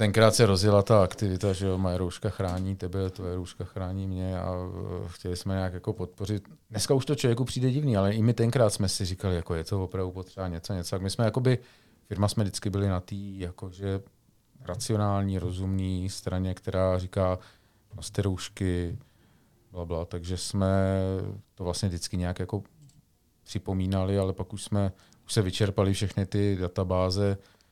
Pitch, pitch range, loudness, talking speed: 95 Hz, 90-105 Hz, -29 LUFS, 170 wpm